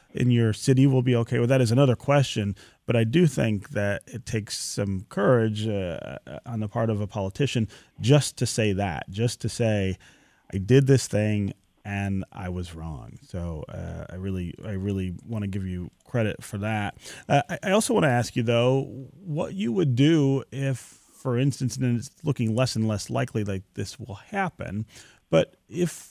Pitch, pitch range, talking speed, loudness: 115 Hz, 100-130 Hz, 195 wpm, -25 LUFS